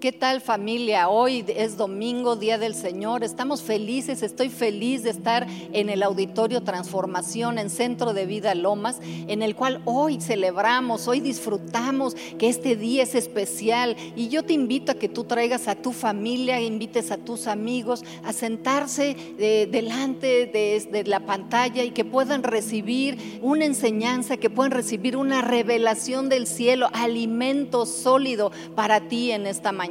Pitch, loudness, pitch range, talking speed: 235 Hz, -24 LUFS, 215-255 Hz, 160 wpm